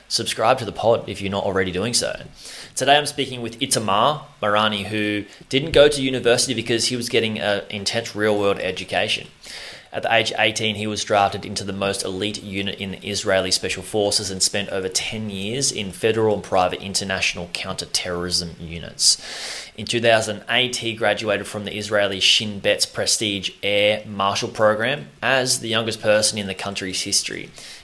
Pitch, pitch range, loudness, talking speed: 105 Hz, 100-115 Hz, -20 LUFS, 175 wpm